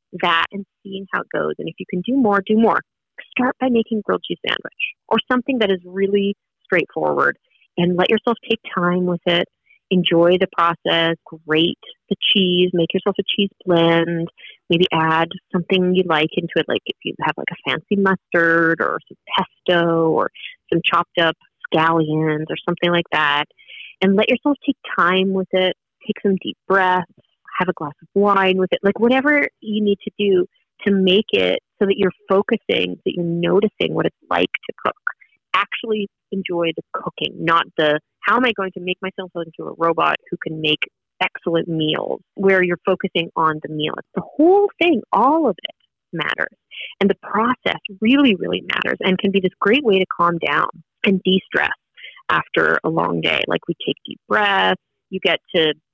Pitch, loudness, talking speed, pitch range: 185 Hz, -19 LUFS, 190 wpm, 170-205 Hz